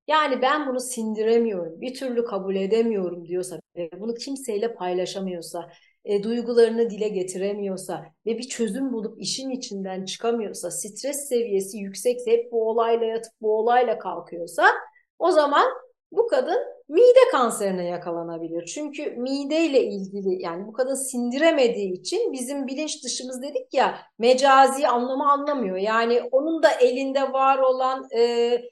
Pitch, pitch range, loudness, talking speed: 235 Hz, 195-275 Hz, -23 LUFS, 135 wpm